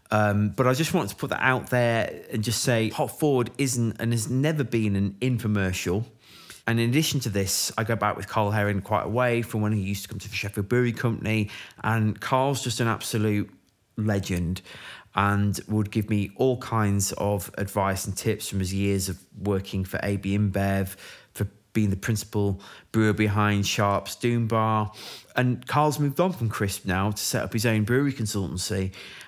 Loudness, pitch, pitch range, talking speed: -26 LUFS, 105 Hz, 100-115 Hz, 195 wpm